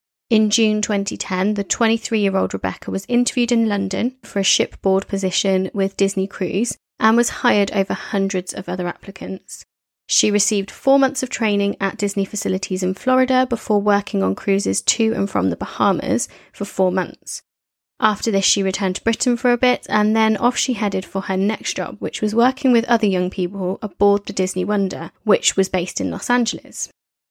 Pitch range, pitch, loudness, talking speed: 190-225 Hz, 200 Hz, -19 LUFS, 185 wpm